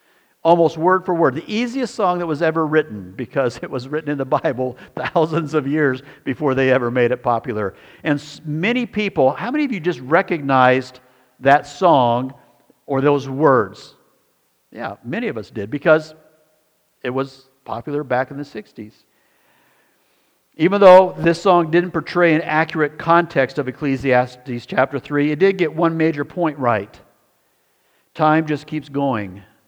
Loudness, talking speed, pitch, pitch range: -18 LUFS, 160 wpm, 150 Hz, 130-165 Hz